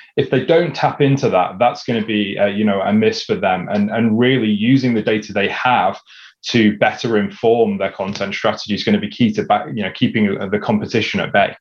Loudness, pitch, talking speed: -17 LUFS, 130 Hz, 235 wpm